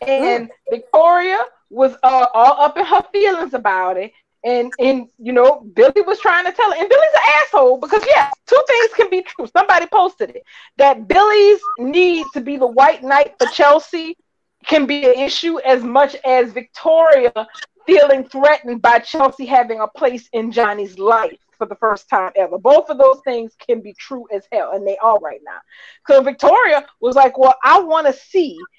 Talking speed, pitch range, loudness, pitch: 190 wpm, 245-350 Hz, -14 LUFS, 275 Hz